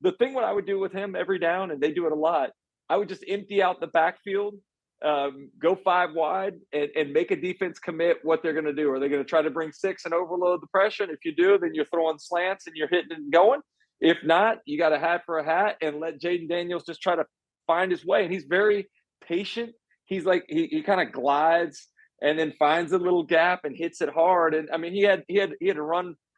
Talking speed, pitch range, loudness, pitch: 255 wpm, 160-195 Hz, -25 LUFS, 175 Hz